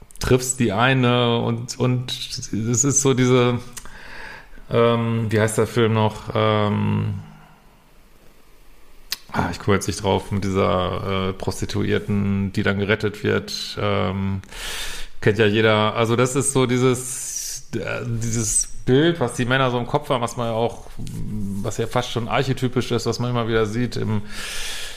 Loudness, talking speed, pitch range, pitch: -21 LUFS, 155 wpm, 105-125 Hz, 115 Hz